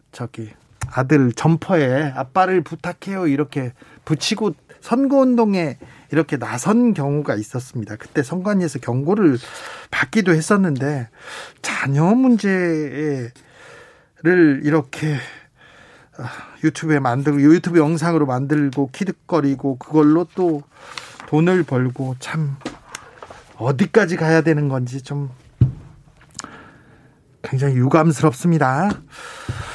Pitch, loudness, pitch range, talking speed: 150 Hz, -19 LUFS, 135-175 Hz, 230 characters per minute